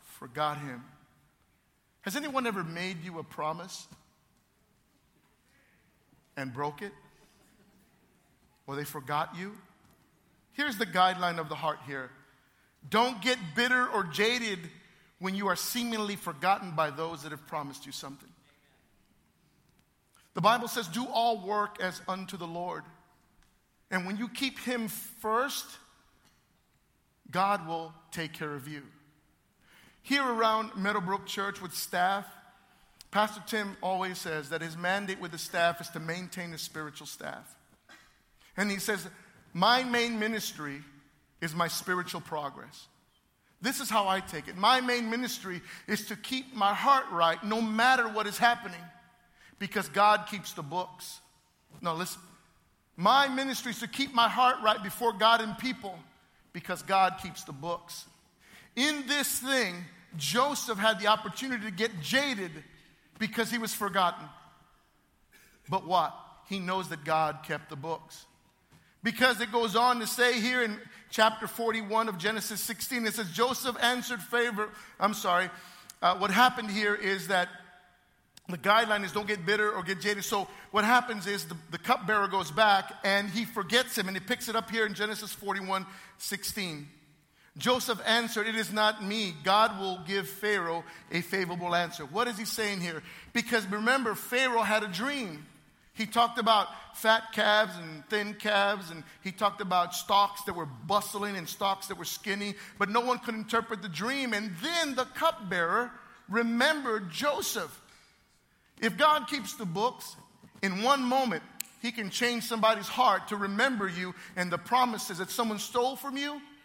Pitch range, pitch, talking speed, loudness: 180-230 Hz, 205 Hz, 155 wpm, -30 LUFS